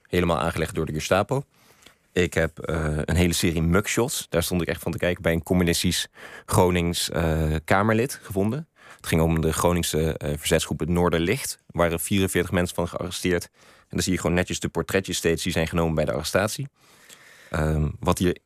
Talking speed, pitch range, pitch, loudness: 190 wpm, 80-90 Hz, 85 Hz, -24 LUFS